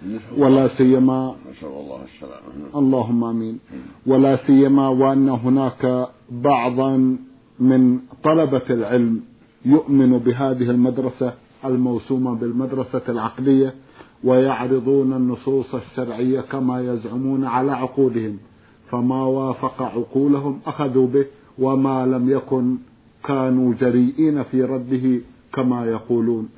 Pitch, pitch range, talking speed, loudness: 130 Hz, 125-135 Hz, 90 wpm, -19 LUFS